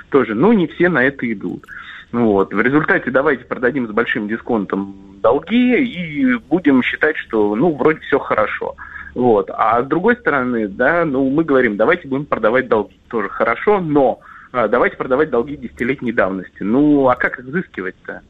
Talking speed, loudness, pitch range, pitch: 165 wpm, -16 LUFS, 115-170 Hz, 135 Hz